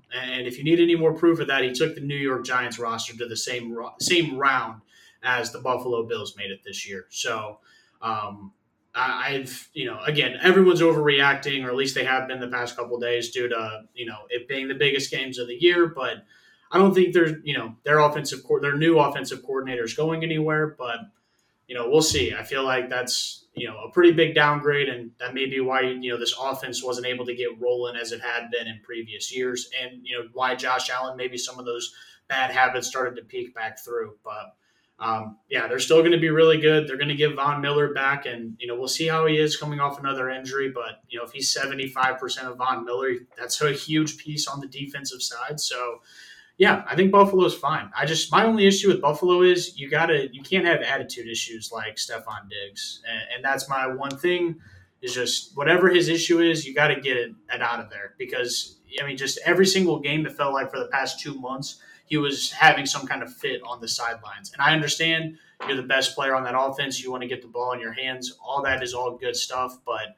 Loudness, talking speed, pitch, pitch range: -23 LUFS, 230 wpm, 135 Hz, 125-155 Hz